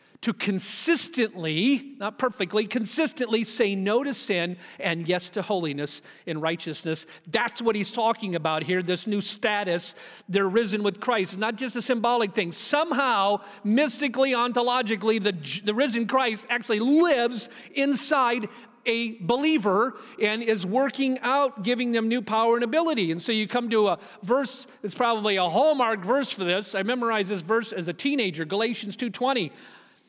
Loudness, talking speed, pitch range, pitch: -25 LUFS, 155 wpm, 200-250 Hz, 225 Hz